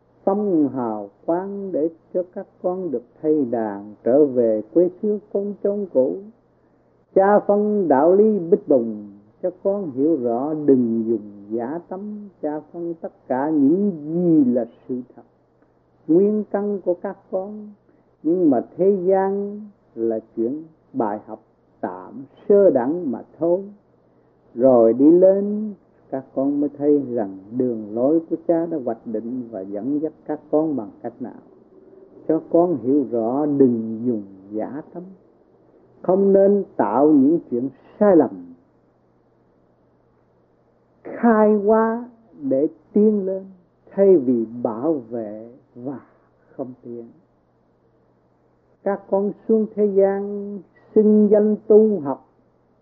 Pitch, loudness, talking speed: 165 Hz, -20 LUFS, 135 wpm